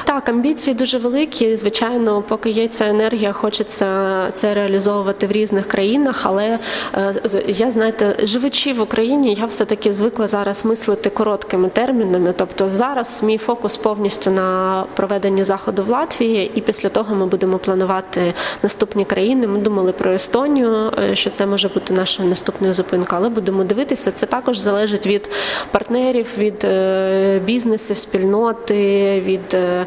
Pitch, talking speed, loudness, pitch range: 205 Hz, 140 wpm, -17 LUFS, 195-225 Hz